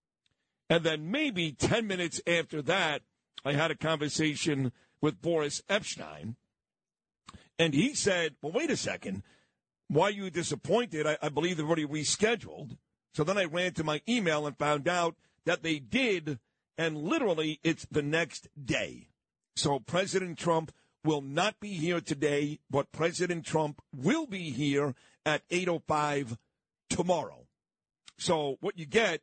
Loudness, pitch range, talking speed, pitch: -31 LUFS, 150-175 Hz, 150 wpm, 160 Hz